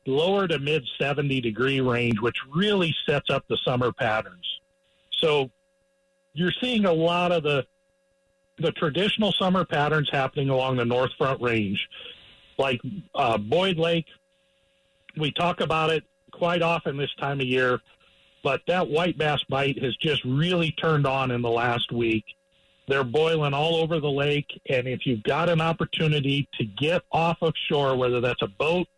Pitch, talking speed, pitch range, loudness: 145 Hz, 165 wpm, 125-170 Hz, -25 LUFS